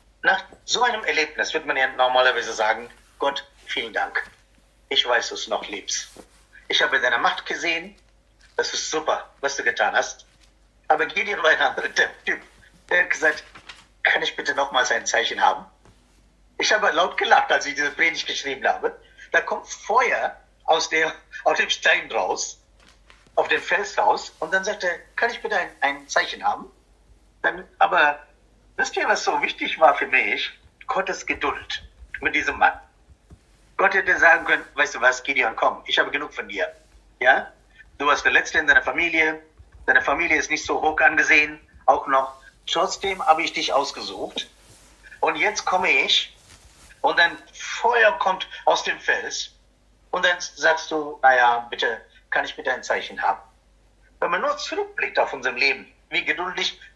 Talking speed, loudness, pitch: 175 wpm, -21 LUFS, 170 Hz